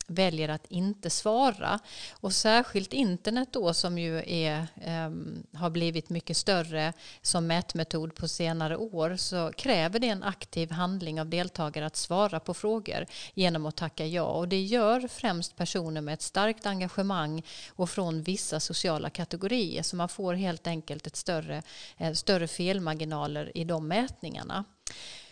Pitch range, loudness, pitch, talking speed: 160-195 Hz, -30 LUFS, 170 Hz, 150 wpm